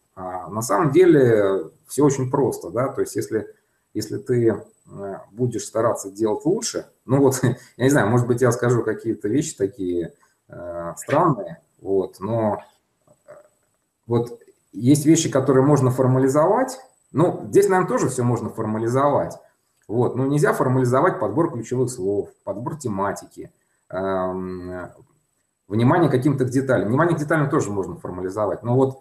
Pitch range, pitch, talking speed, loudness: 105-145 Hz, 125 Hz, 130 wpm, -21 LUFS